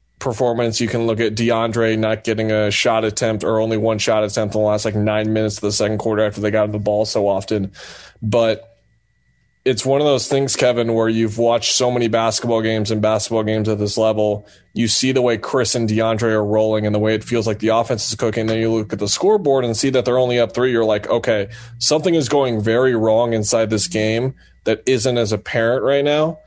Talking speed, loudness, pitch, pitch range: 230 wpm, -18 LUFS, 110 Hz, 110-120 Hz